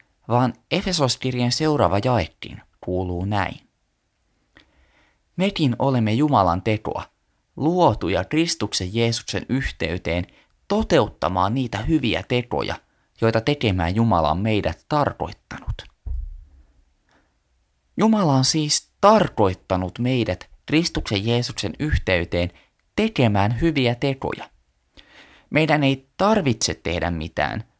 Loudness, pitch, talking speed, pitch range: -21 LUFS, 110 Hz, 85 wpm, 90-135 Hz